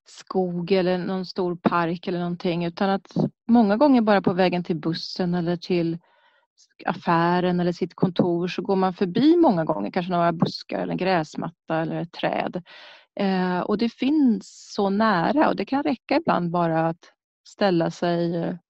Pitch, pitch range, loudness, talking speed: 185 Hz, 175-210 Hz, -23 LUFS, 165 wpm